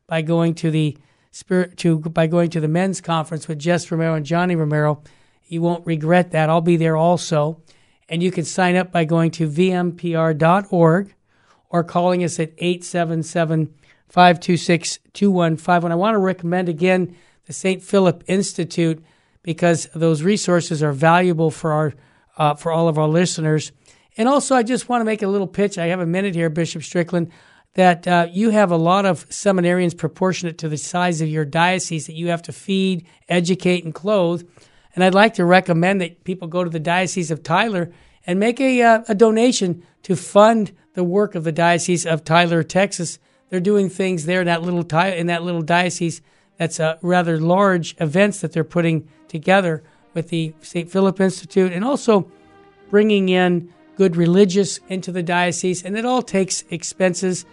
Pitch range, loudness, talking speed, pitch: 165-185 Hz, -19 LUFS, 180 wpm, 175 Hz